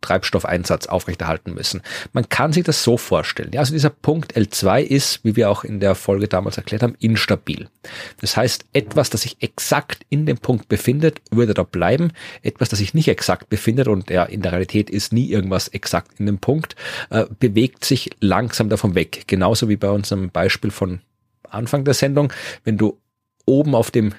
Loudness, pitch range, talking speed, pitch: -19 LUFS, 100-130 Hz, 190 wpm, 110 Hz